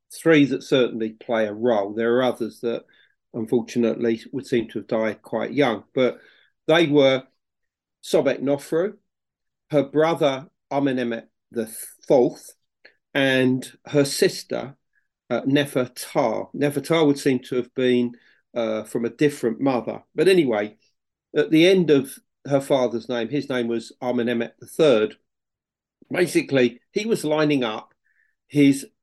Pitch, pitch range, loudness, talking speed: 130 Hz, 120-145 Hz, -22 LUFS, 130 wpm